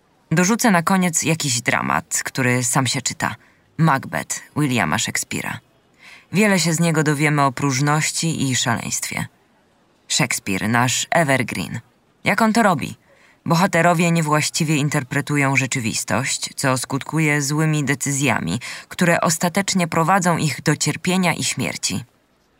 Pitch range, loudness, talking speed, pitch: 135-170 Hz, -19 LUFS, 115 wpm, 150 Hz